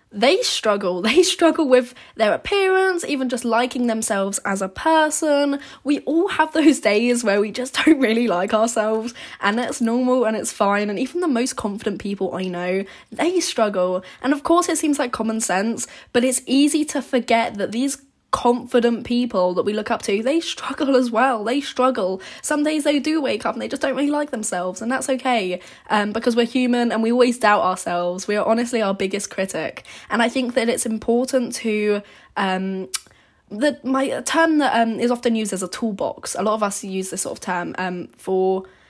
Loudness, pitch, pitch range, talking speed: -20 LUFS, 240 Hz, 205-270 Hz, 200 wpm